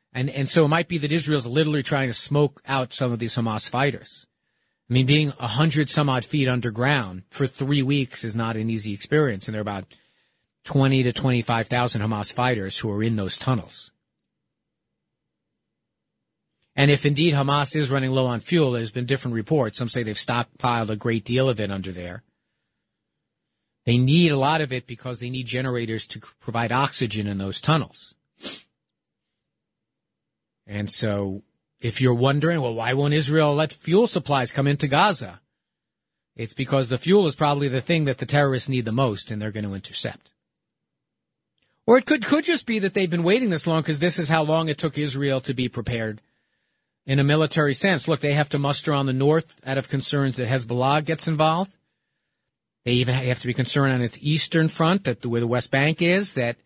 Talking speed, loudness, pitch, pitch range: 195 wpm, -22 LUFS, 135 Hz, 120-150 Hz